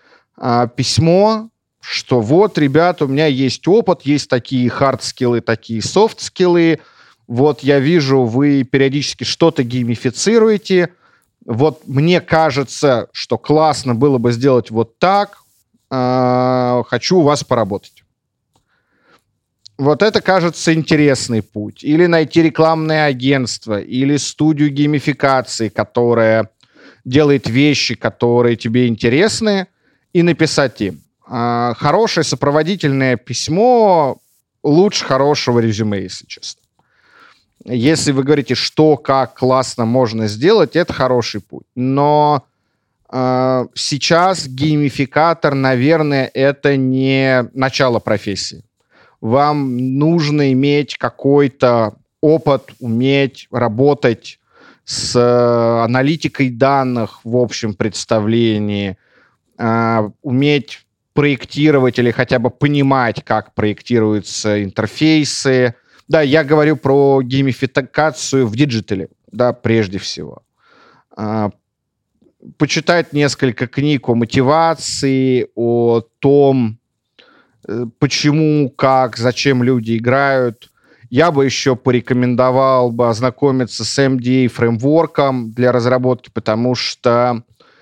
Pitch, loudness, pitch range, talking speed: 130 Hz, -14 LUFS, 120-145 Hz, 100 wpm